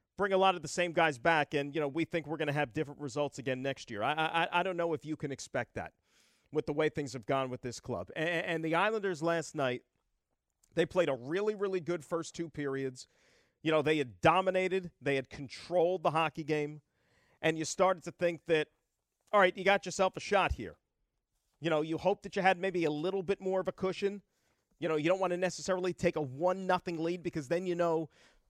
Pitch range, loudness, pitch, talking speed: 150-185 Hz, -33 LUFS, 165 Hz, 235 wpm